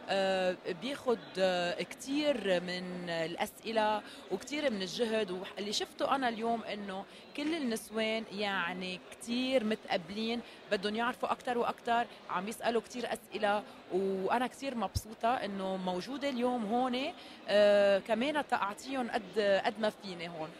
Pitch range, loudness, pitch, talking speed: 195-250 Hz, -34 LUFS, 220 Hz, 115 wpm